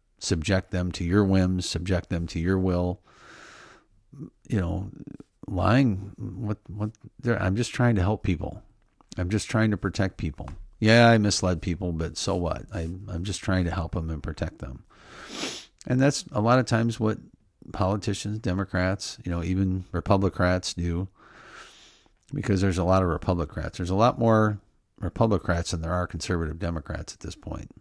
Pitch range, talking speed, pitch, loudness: 85-105 Hz, 165 wpm, 95 Hz, -26 LUFS